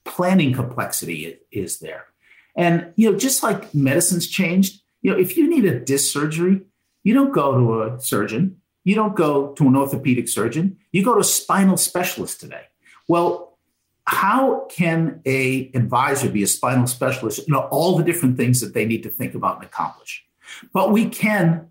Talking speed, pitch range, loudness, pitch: 180 wpm, 130-190 Hz, -19 LUFS, 170 Hz